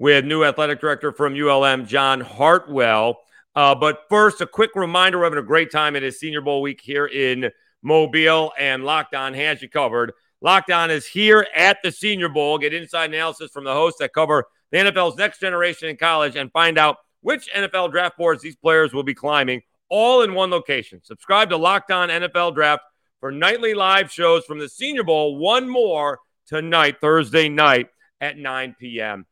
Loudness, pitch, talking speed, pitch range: -18 LUFS, 155 Hz, 185 wpm, 140-175 Hz